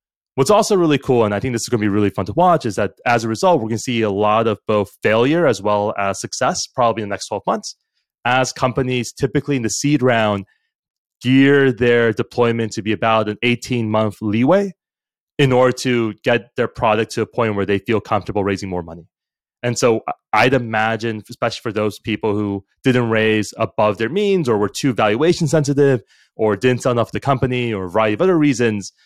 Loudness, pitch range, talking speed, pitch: -18 LUFS, 105-130 Hz, 215 wpm, 115 Hz